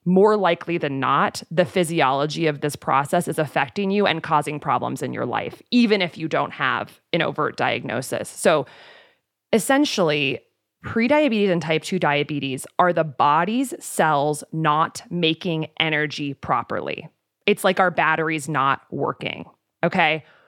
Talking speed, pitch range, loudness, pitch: 140 wpm, 150-190 Hz, -21 LUFS, 160 Hz